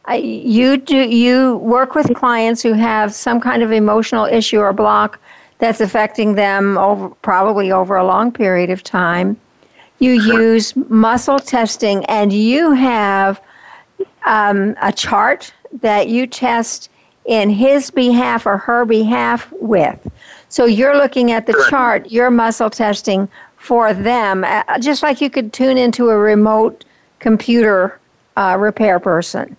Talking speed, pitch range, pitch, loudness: 140 wpm, 210-245 Hz, 225 Hz, -14 LUFS